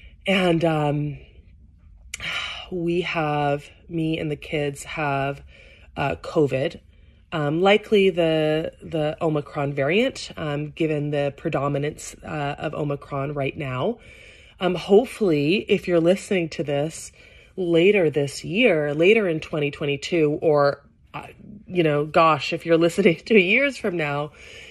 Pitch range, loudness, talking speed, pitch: 145-175 Hz, -22 LUFS, 125 wpm, 155 Hz